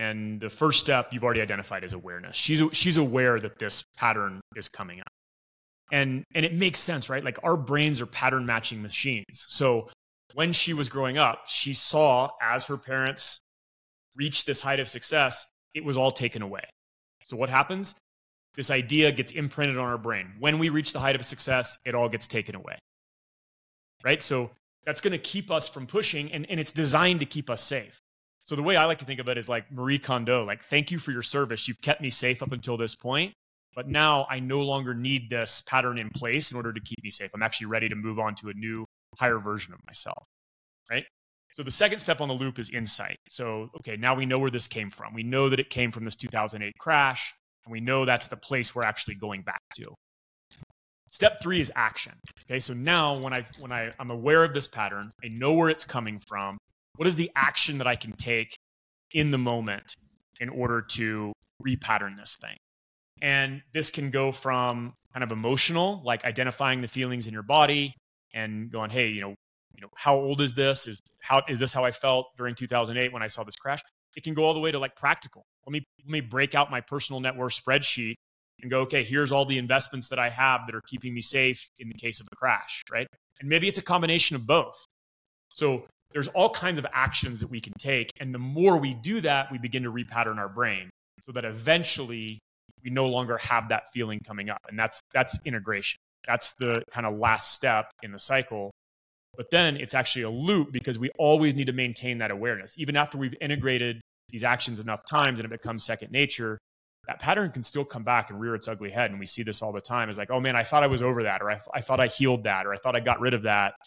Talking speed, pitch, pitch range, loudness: 225 wpm, 125 Hz, 110-140 Hz, -26 LUFS